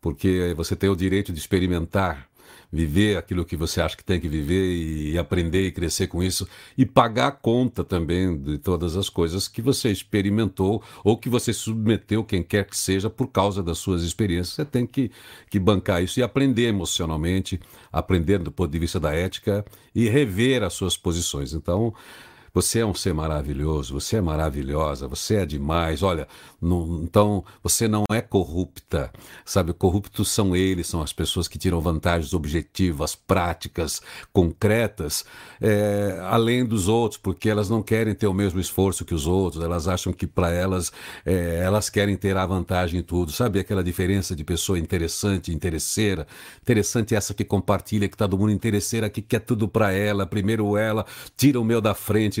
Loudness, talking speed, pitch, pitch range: -24 LUFS, 180 wpm, 95 Hz, 85-105 Hz